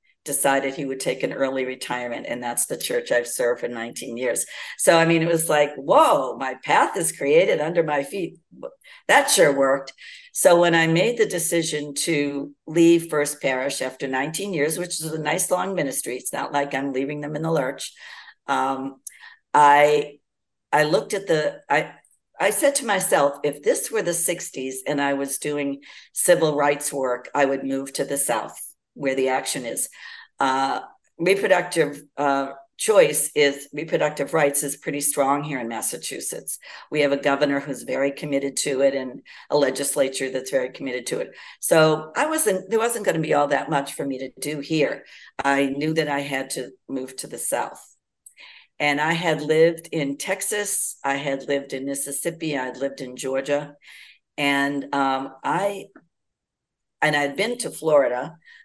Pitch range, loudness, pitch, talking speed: 140-165 Hz, -22 LUFS, 145 Hz, 175 wpm